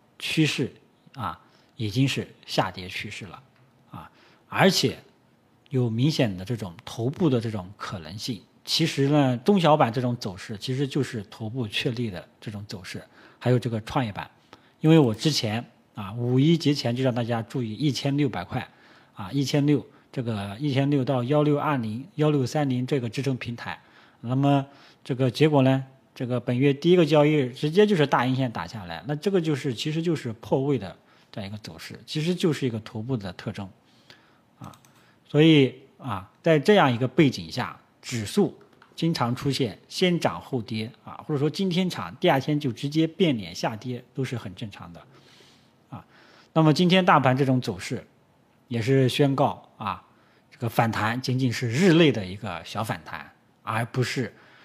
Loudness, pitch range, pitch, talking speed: -25 LUFS, 115-145 Hz, 130 Hz, 260 characters per minute